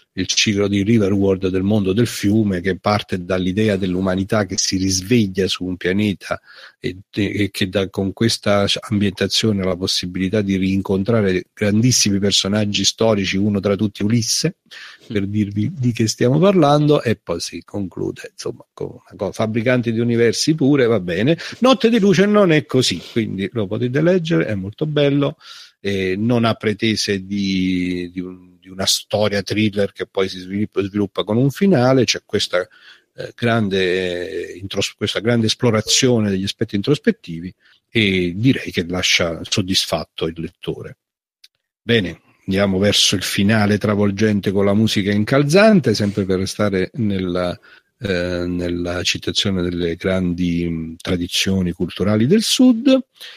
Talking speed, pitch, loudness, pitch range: 145 wpm, 100 Hz, -18 LUFS, 95-115 Hz